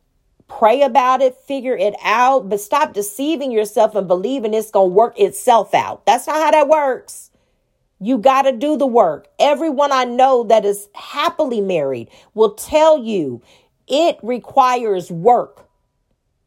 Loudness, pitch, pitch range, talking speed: -16 LUFS, 250 Hz, 210-280 Hz, 155 wpm